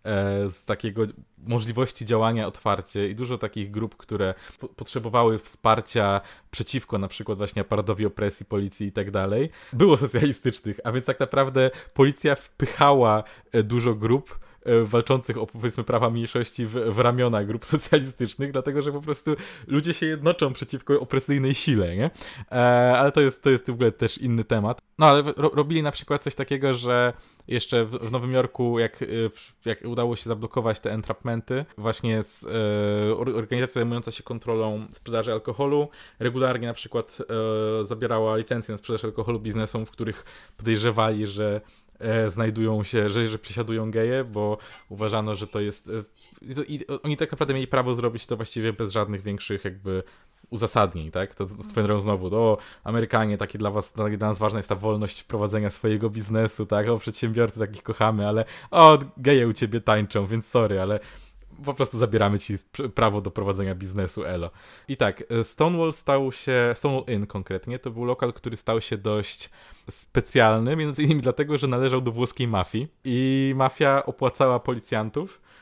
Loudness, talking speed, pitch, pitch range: -24 LUFS, 165 wpm, 115 Hz, 105-130 Hz